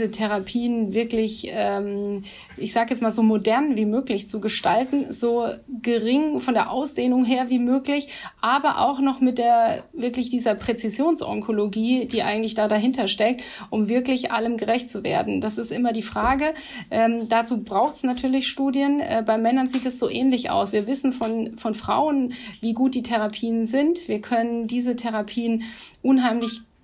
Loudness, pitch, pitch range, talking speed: -22 LUFS, 235 Hz, 220-255 Hz, 165 wpm